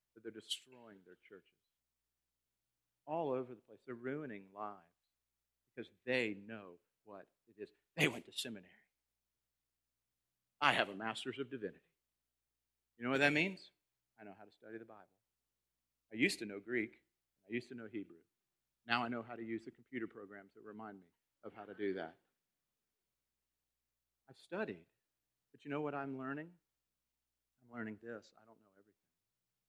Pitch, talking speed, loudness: 95 Hz, 165 wpm, -40 LUFS